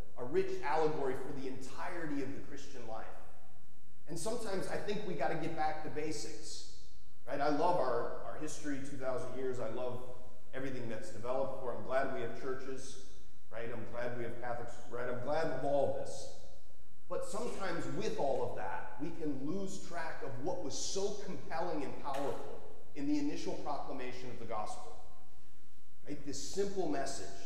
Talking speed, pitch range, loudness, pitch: 175 wpm, 120-160 Hz, -40 LUFS, 135 Hz